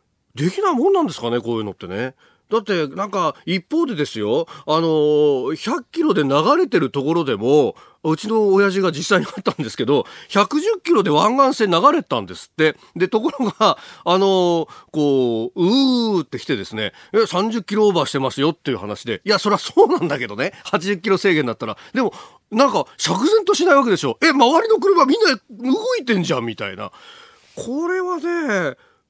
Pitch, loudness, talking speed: 205 Hz, -18 LUFS, 360 characters per minute